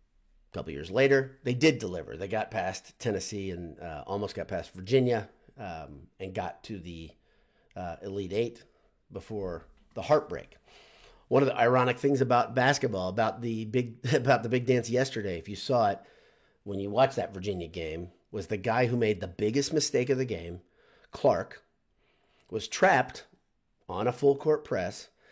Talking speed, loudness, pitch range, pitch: 170 wpm, -29 LUFS, 95-130 Hz, 115 Hz